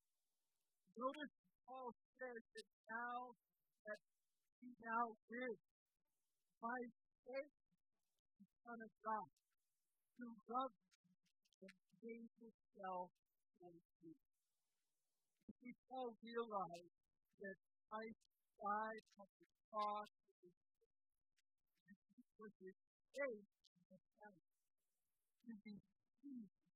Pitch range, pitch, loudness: 190-240 Hz, 215 Hz, -52 LUFS